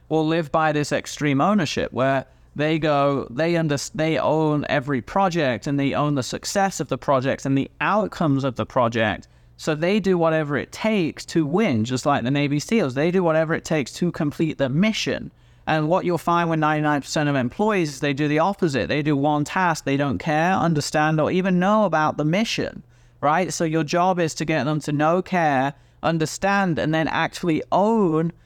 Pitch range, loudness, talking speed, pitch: 140-170 Hz, -22 LUFS, 195 wpm, 155 Hz